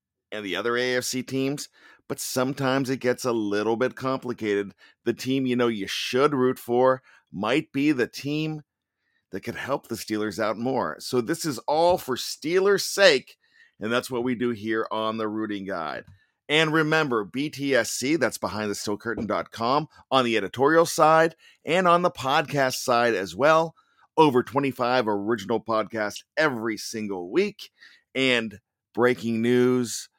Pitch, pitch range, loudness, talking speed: 125 Hz, 110-140 Hz, -24 LUFS, 155 wpm